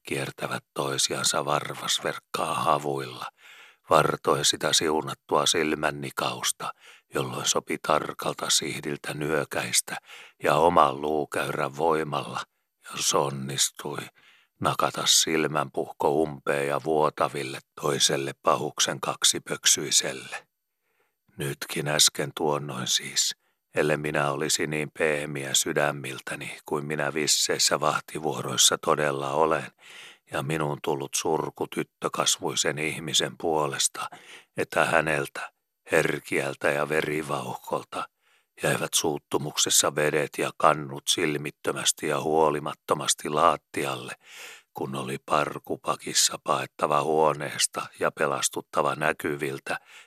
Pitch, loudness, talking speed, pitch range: 75 Hz, -25 LUFS, 90 wpm, 70-75 Hz